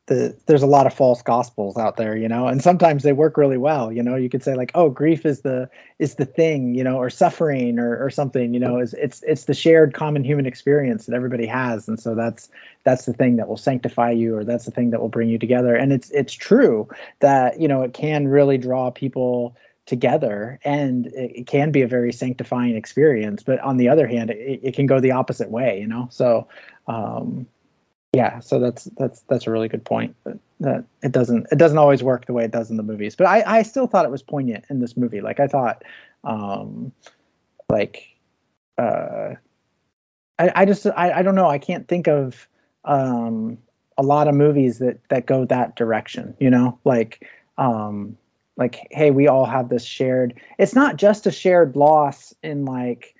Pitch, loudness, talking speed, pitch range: 130 Hz, -19 LUFS, 210 wpm, 120-145 Hz